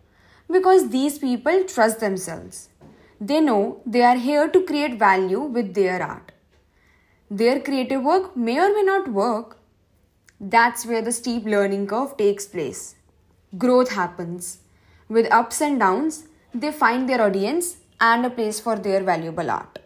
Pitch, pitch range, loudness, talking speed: 230 Hz, 195-275 Hz, -21 LUFS, 150 wpm